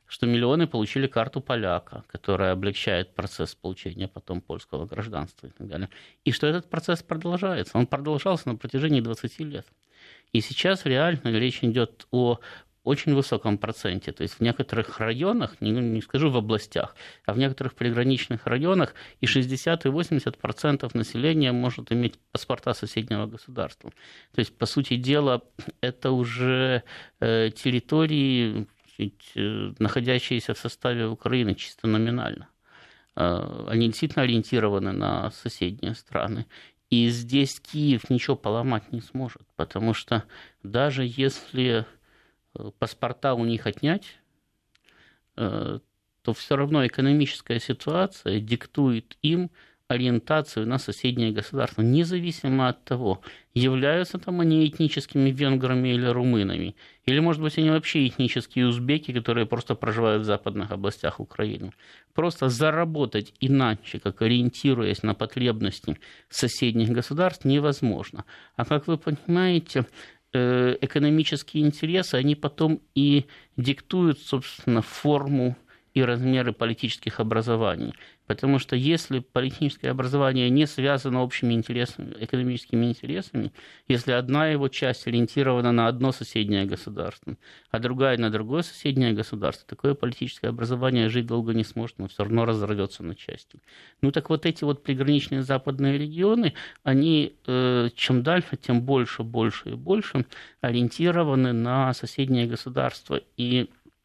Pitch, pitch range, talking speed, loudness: 125 Hz, 115-140 Hz, 125 wpm, -25 LUFS